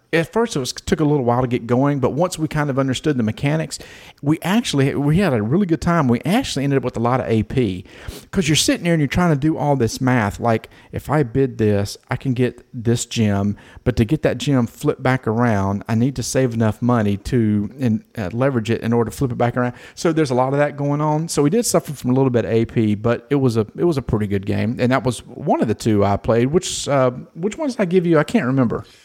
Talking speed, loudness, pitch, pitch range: 270 wpm, -19 LUFS, 130 Hz, 115-150 Hz